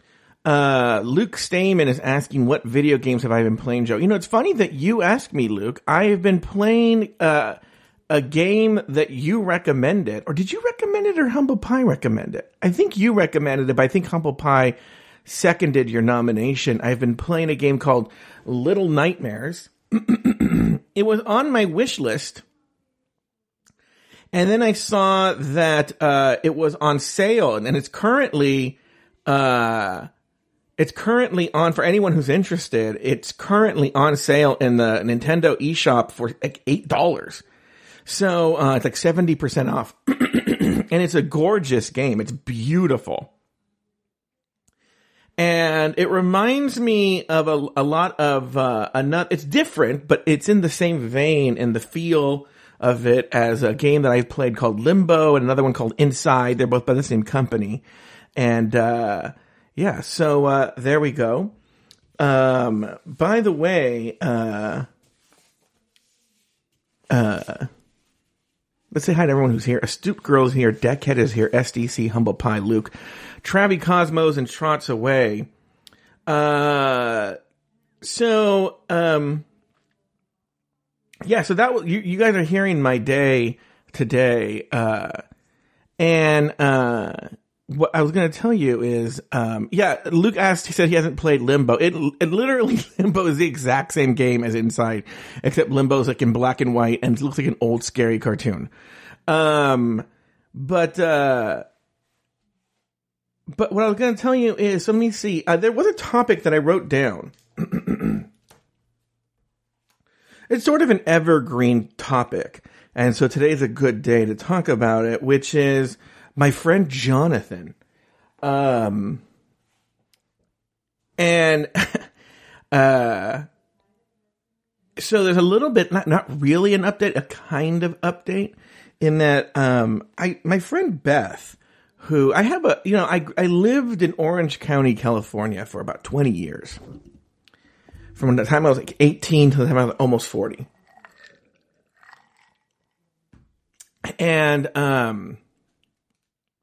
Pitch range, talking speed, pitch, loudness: 125-180 Hz, 145 wpm, 150 Hz, -19 LUFS